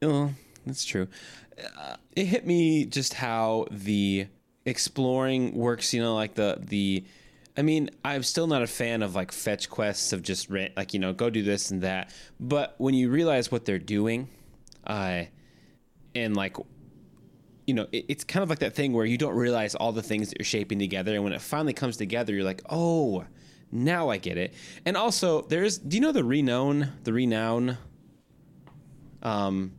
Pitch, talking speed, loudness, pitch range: 120 Hz, 185 wpm, -28 LUFS, 105-145 Hz